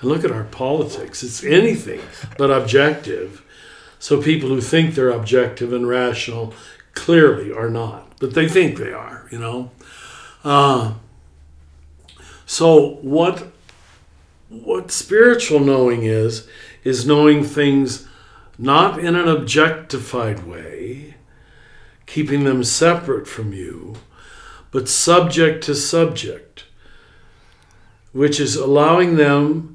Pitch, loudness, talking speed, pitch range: 135 Hz, -16 LUFS, 110 wpm, 115-155 Hz